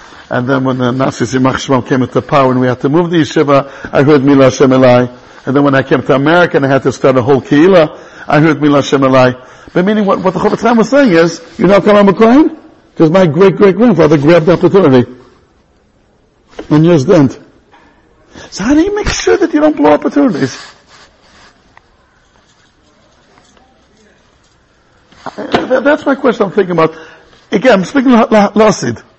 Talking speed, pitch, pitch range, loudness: 175 wpm, 160 Hz, 135-205 Hz, -9 LUFS